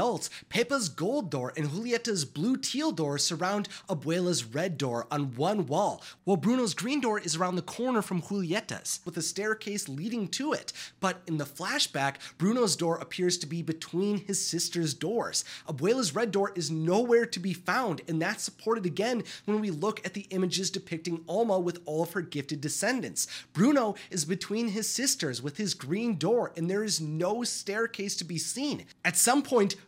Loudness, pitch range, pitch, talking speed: -30 LUFS, 165-220 Hz, 190 Hz, 180 wpm